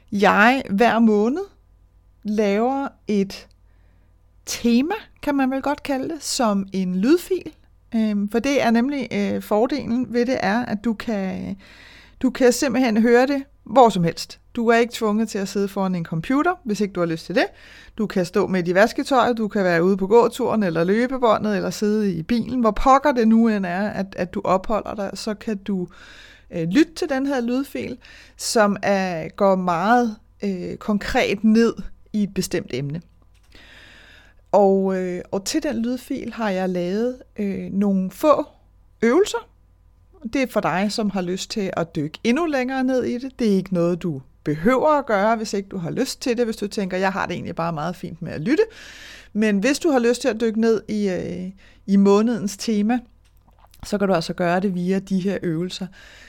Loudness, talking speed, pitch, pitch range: -21 LUFS, 190 wpm, 210 Hz, 185-245 Hz